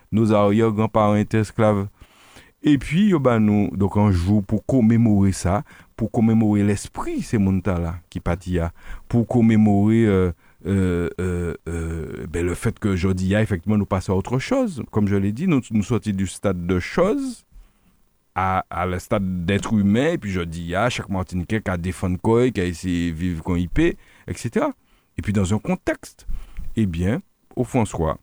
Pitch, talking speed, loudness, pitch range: 100 Hz, 175 wpm, -21 LUFS, 90-110 Hz